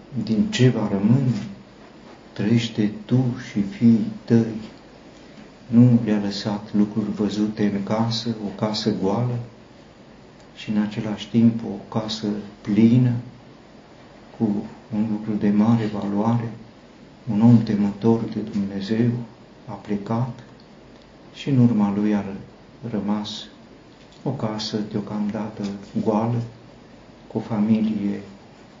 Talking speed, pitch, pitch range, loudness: 110 wpm, 110 Hz, 105-115 Hz, -22 LUFS